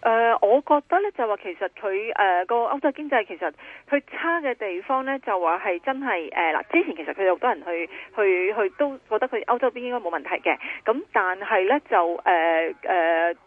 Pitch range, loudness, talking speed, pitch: 185-280 Hz, -23 LUFS, 300 characters per minute, 230 Hz